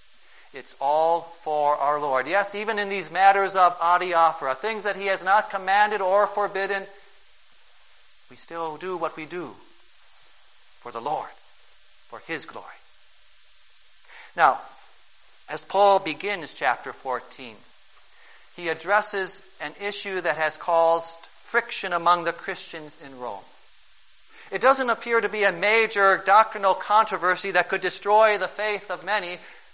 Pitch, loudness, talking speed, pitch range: 190 Hz, -23 LUFS, 135 wpm, 170-205 Hz